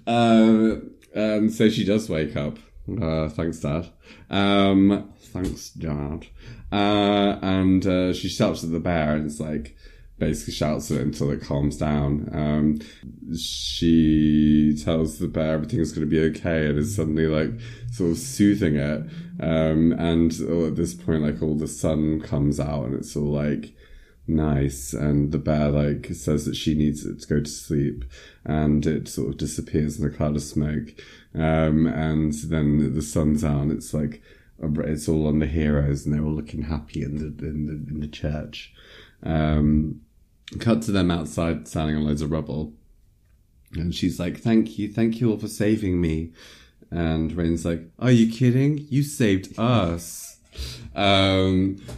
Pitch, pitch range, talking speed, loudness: 80 Hz, 75-95 Hz, 170 wpm, -23 LUFS